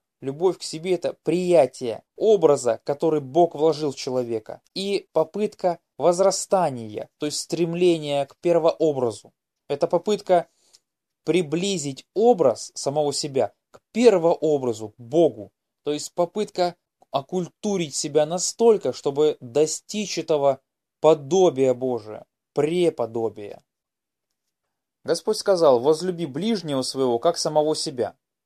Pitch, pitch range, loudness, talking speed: 160 Hz, 140-180 Hz, -23 LUFS, 105 wpm